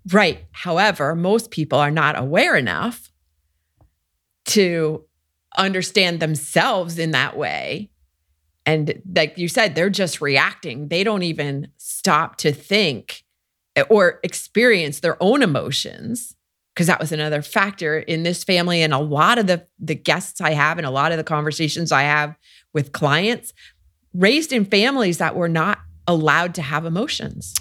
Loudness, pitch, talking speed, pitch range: -19 LUFS, 160 Hz, 150 wpm, 145-185 Hz